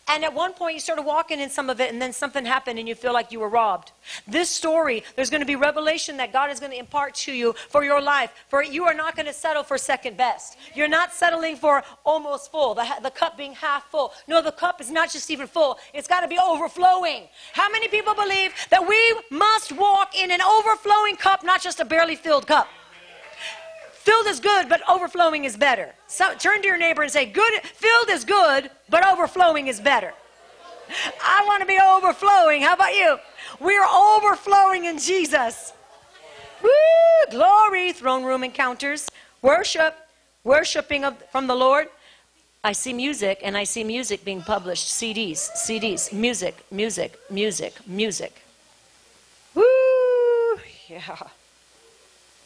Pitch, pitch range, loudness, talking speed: 315 Hz, 275-370 Hz, -20 LUFS, 180 wpm